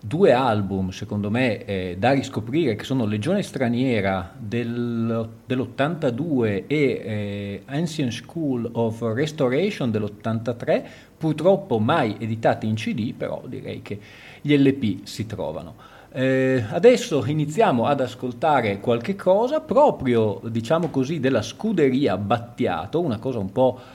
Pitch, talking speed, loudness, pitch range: 125 Hz, 125 wpm, -23 LUFS, 115-140 Hz